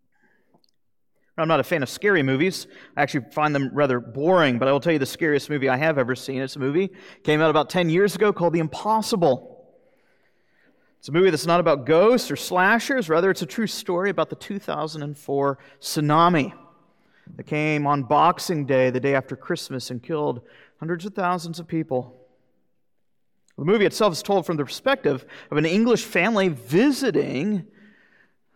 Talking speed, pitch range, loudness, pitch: 175 wpm, 140-190 Hz, -22 LUFS, 160 Hz